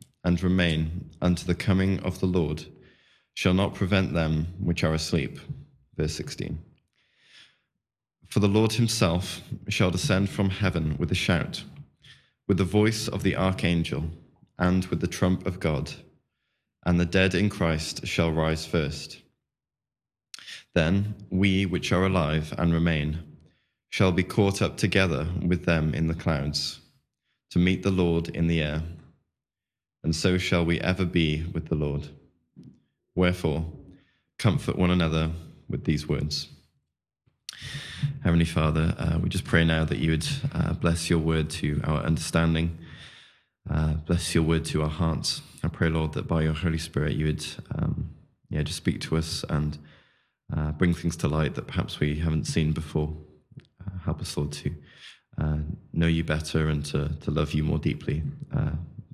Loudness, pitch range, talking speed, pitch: -26 LUFS, 80-90 Hz, 160 wpm, 85 Hz